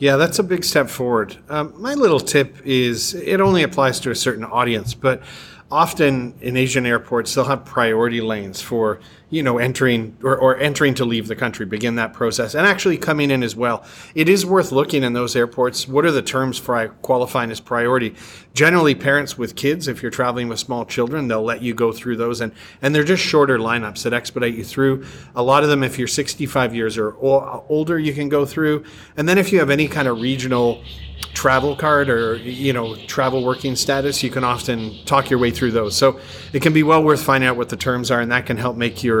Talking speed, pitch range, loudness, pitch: 220 wpm, 120-145 Hz, -18 LUFS, 130 Hz